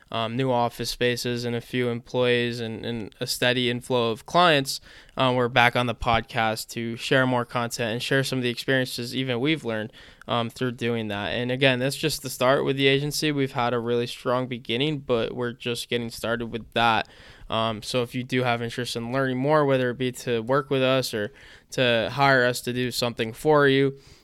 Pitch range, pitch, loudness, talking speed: 115-130 Hz, 125 Hz, -24 LUFS, 215 wpm